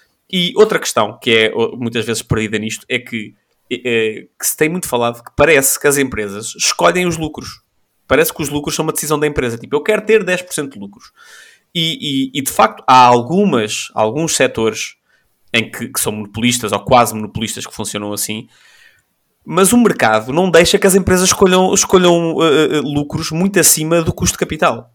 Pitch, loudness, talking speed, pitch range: 145 Hz, -14 LUFS, 190 wpm, 115-175 Hz